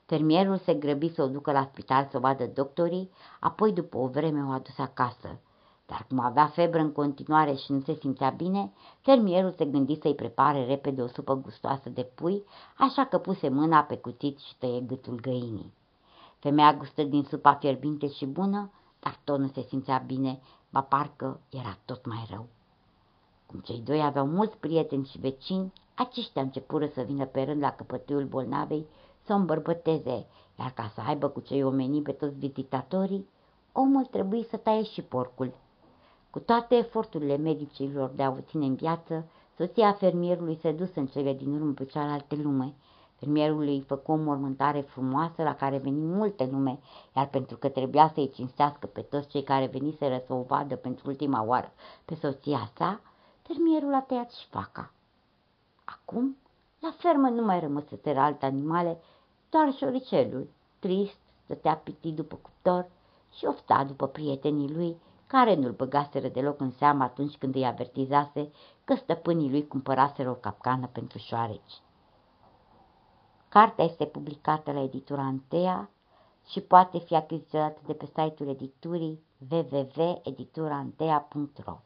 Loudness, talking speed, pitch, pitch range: -28 LUFS, 160 wpm, 145 Hz, 135-165 Hz